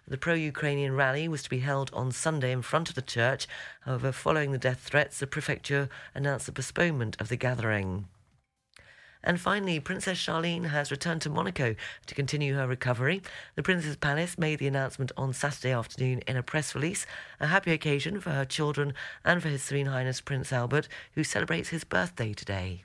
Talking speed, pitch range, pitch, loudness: 185 wpm, 130-155 Hz, 140 Hz, -30 LUFS